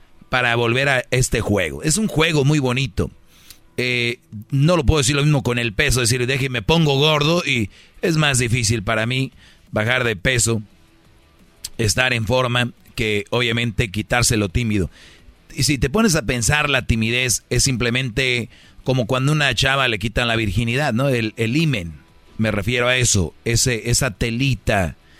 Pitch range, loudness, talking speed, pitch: 110-135 Hz, -19 LUFS, 170 wpm, 120 Hz